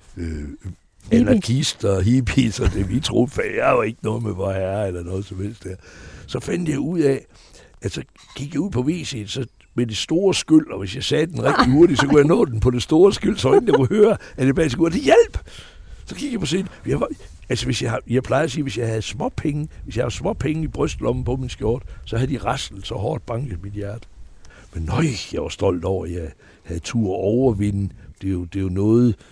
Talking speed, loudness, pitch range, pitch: 245 wpm, -20 LUFS, 95-140 Hz, 115 Hz